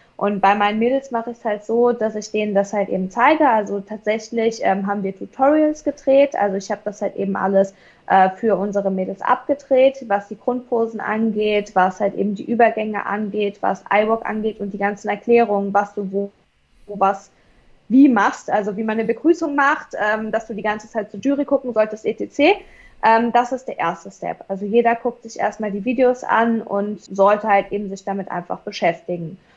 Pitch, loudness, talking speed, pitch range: 215 Hz, -19 LUFS, 200 wpm, 200-235 Hz